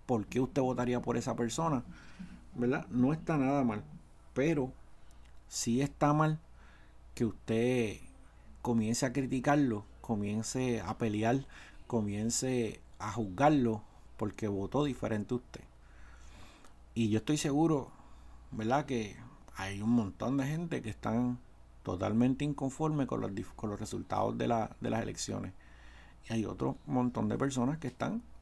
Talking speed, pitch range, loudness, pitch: 135 wpm, 105-135 Hz, -34 LUFS, 120 Hz